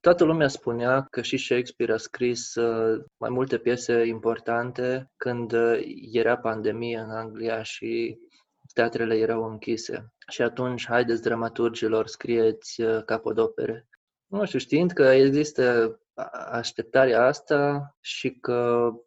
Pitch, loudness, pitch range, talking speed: 120 Hz, -25 LUFS, 115-140 Hz, 115 wpm